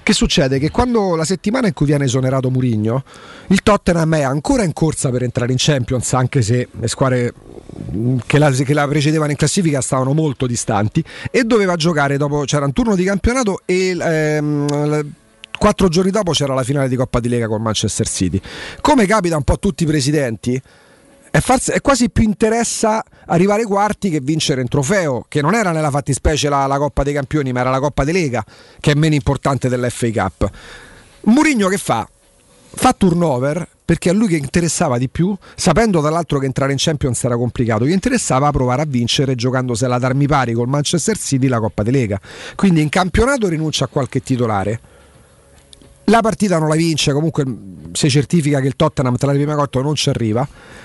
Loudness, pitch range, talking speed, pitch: -16 LUFS, 130-175 Hz, 190 wpm, 145 Hz